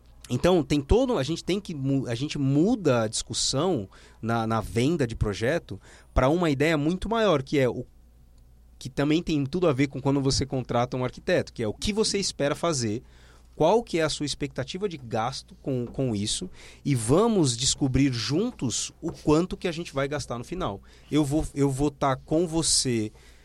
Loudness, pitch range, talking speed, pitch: -26 LUFS, 115-160 Hz, 190 wpm, 140 Hz